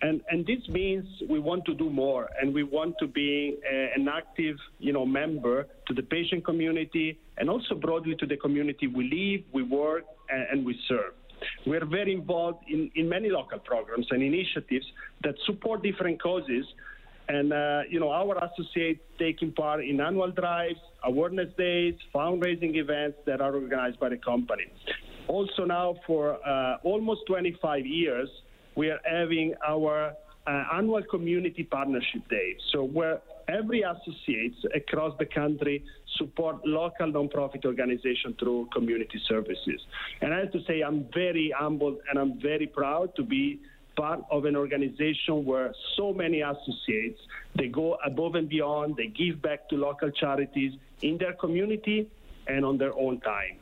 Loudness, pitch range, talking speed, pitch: -29 LUFS, 140-175 Hz, 160 wpm, 155 Hz